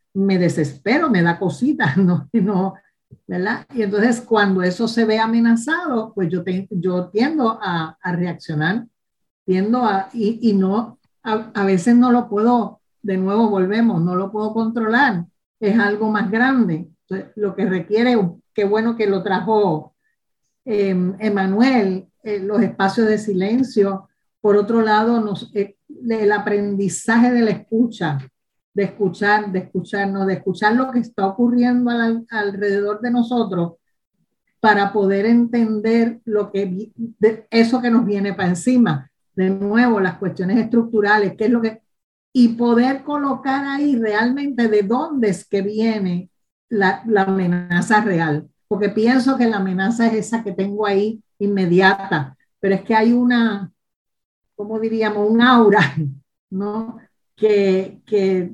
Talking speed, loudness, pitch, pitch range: 145 wpm, -18 LUFS, 210 Hz, 190-230 Hz